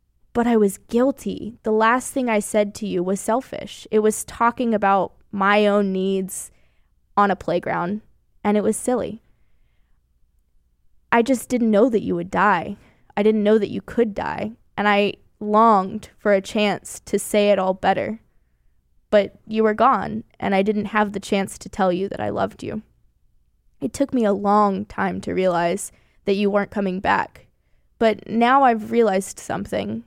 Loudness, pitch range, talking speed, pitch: -21 LUFS, 190-220 Hz, 175 wpm, 205 Hz